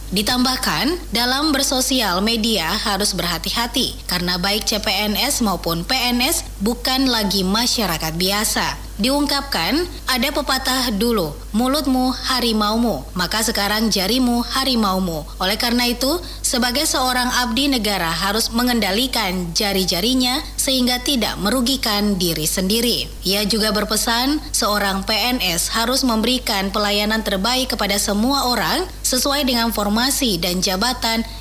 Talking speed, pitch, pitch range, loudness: 110 wpm, 230 Hz, 200-255 Hz, -18 LUFS